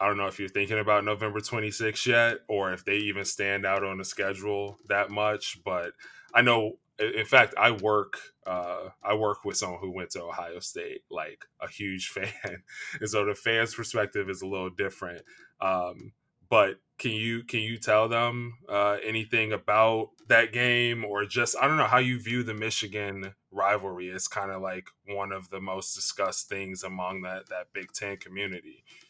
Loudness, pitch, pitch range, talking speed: -28 LUFS, 105 Hz, 95-110 Hz, 190 wpm